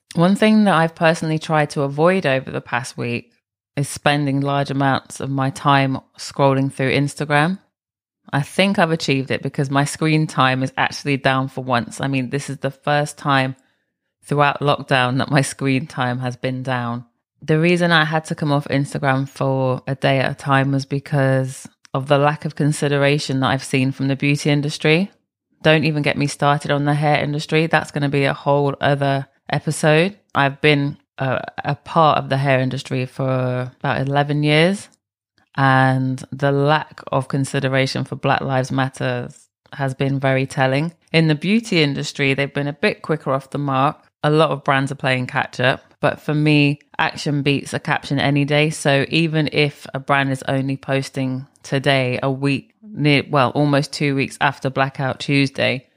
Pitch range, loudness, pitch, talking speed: 135-150 Hz, -19 LUFS, 140 Hz, 185 wpm